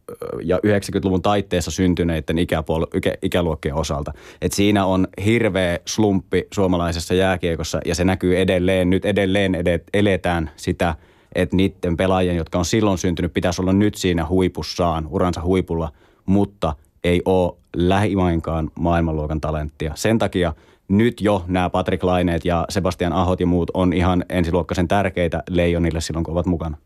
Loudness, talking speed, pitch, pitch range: -20 LUFS, 145 wpm, 90 Hz, 85-95 Hz